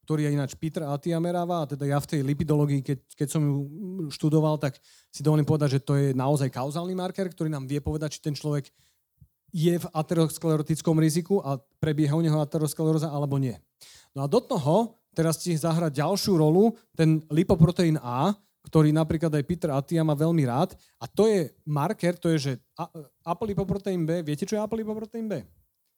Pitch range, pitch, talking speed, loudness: 145-175 Hz, 160 Hz, 180 wpm, -26 LUFS